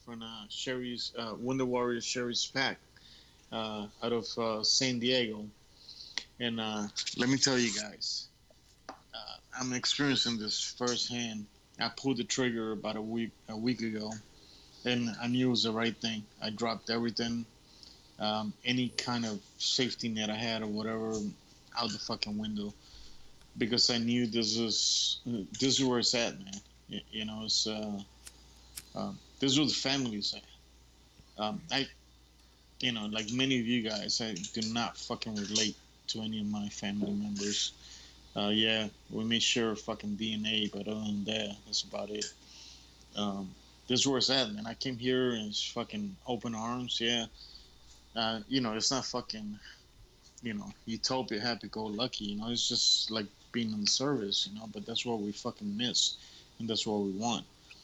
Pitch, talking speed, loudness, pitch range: 110 Hz, 175 wpm, -32 LUFS, 105-120 Hz